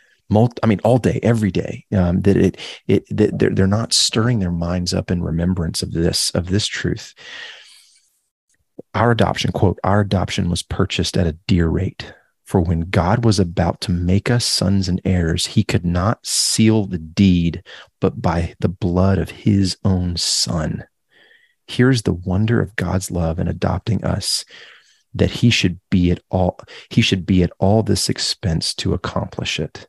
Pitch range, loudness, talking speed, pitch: 90-105 Hz, -18 LUFS, 175 wpm, 95 Hz